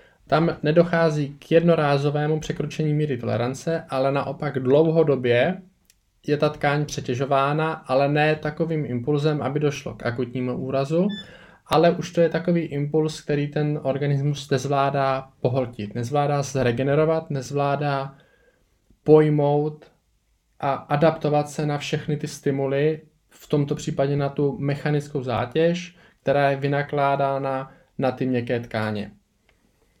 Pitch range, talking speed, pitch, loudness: 135-155 Hz, 120 wpm, 145 Hz, -23 LUFS